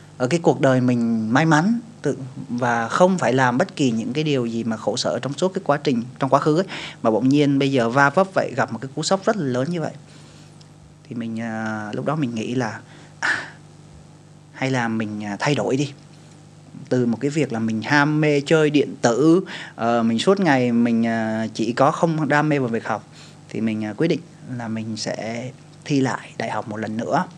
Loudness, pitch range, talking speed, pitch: -21 LUFS, 115-155 Hz, 215 wpm, 135 Hz